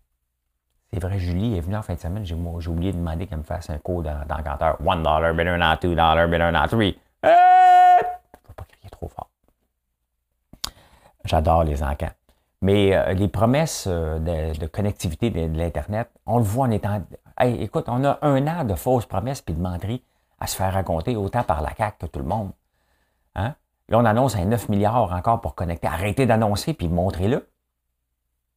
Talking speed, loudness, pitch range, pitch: 190 wpm, -22 LUFS, 80-110 Hz, 90 Hz